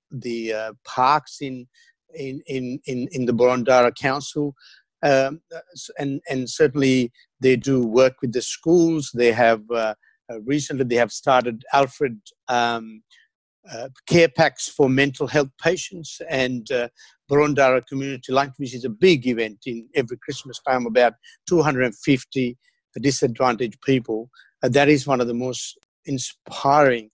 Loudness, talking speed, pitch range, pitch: -21 LUFS, 145 wpm, 125-145 Hz, 130 Hz